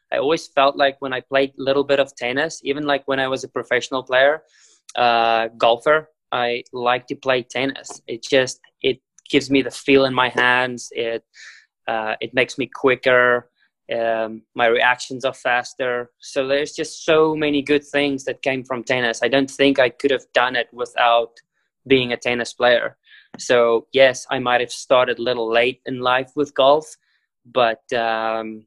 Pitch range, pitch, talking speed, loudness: 120-140 Hz, 130 Hz, 180 wpm, -19 LUFS